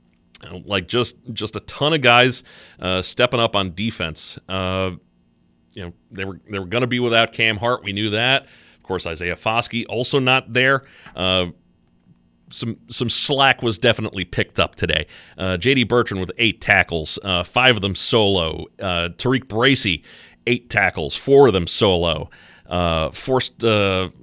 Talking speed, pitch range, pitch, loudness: 170 wpm, 90-120 Hz, 105 Hz, -19 LUFS